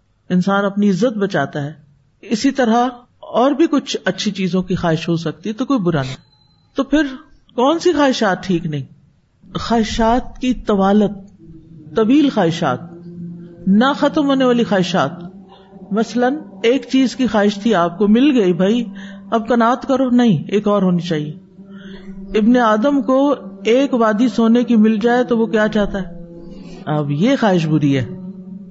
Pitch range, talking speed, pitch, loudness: 175-245 Hz, 160 wpm, 205 Hz, -16 LUFS